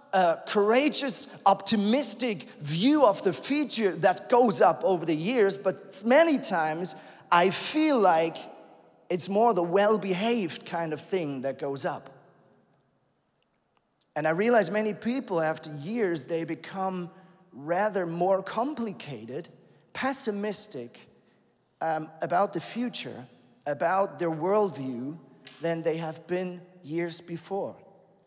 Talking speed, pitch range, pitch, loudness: 120 wpm, 165-215 Hz, 185 Hz, -27 LUFS